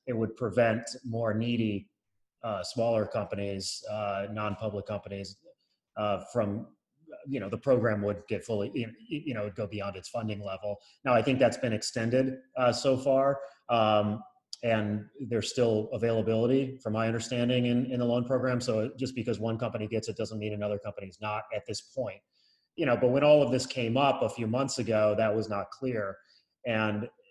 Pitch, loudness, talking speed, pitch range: 115 Hz, -30 LUFS, 185 wpm, 105-125 Hz